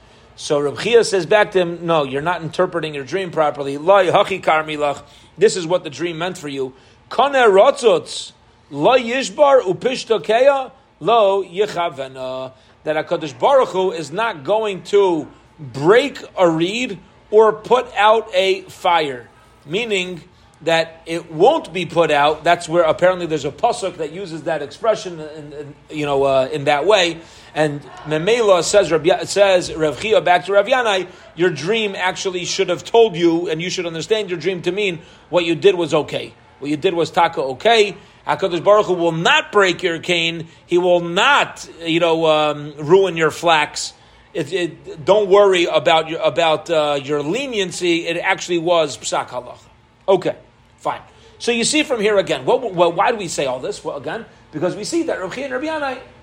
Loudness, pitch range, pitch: -17 LUFS, 155-200 Hz, 175 Hz